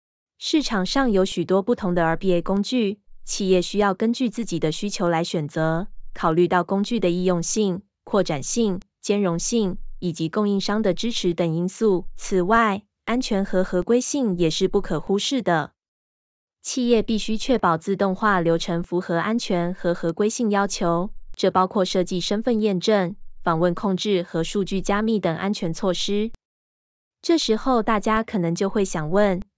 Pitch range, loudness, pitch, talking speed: 175-215 Hz, -22 LUFS, 195 Hz, 250 characters per minute